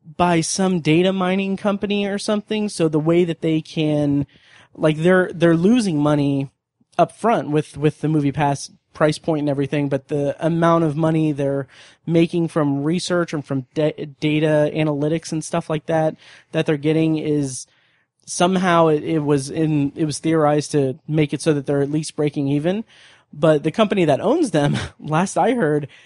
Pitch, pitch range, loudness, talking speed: 155 Hz, 150-170 Hz, -19 LUFS, 180 wpm